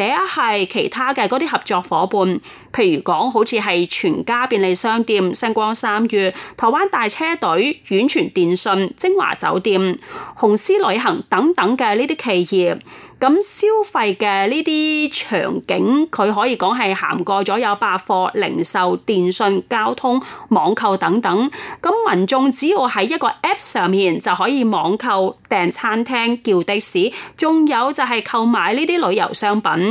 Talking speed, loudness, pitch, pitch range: 235 characters per minute, -17 LUFS, 230 Hz, 195-310 Hz